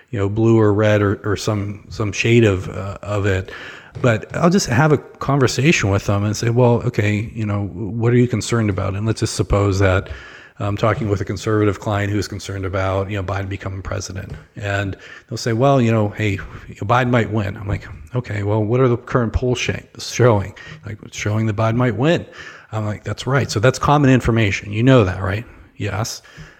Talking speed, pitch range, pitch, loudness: 210 wpm, 100-120 Hz, 110 Hz, -18 LUFS